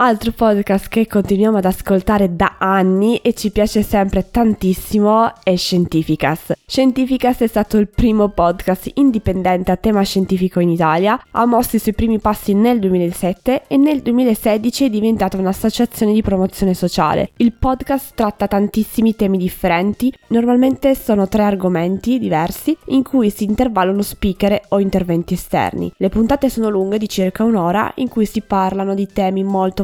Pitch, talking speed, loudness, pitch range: 210 Hz, 155 wpm, -16 LUFS, 190-230 Hz